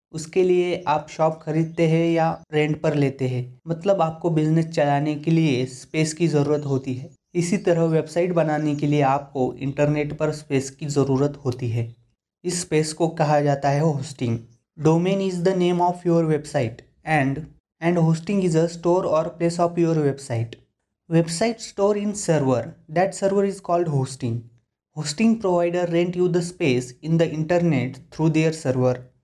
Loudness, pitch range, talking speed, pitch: -22 LUFS, 140-170 Hz, 170 wpm, 155 Hz